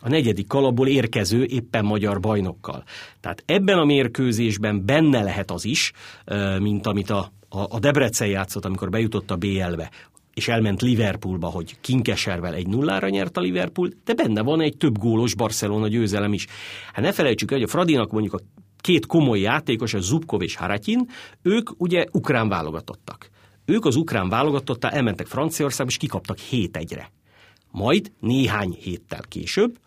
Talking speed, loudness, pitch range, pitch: 155 wpm, -22 LUFS, 100-135 Hz, 110 Hz